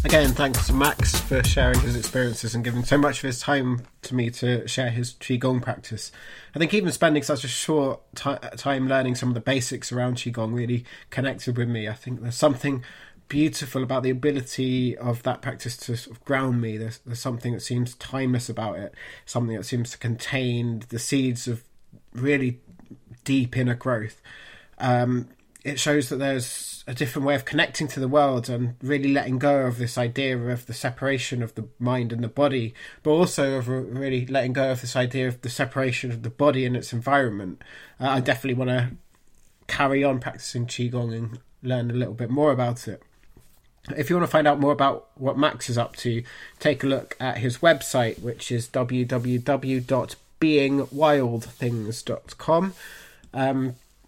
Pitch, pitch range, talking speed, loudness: 125 Hz, 120-140 Hz, 185 wpm, -25 LUFS